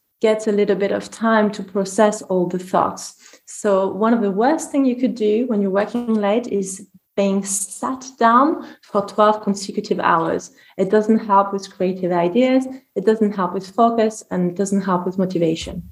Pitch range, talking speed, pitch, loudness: 195-225 Hz, 185 wpm, 205 Hz, -19 LUFS